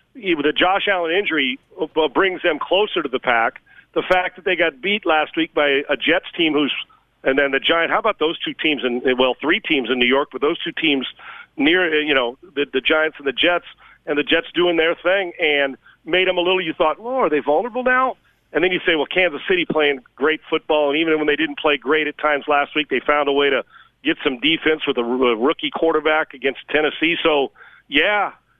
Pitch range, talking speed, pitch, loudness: 145-180 Hz, 230 wpm, 155 Hz, -19 LUFS